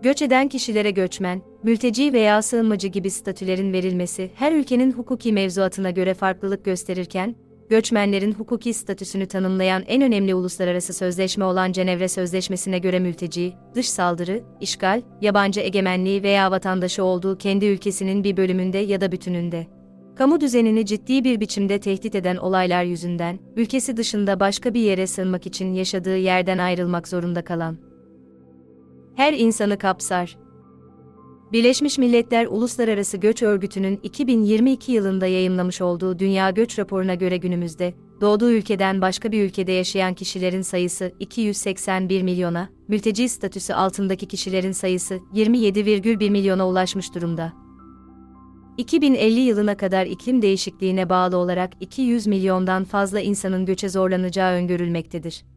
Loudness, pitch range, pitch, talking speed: -21 LUFS, 185-210 Hz, 190 Hz, 125 wpm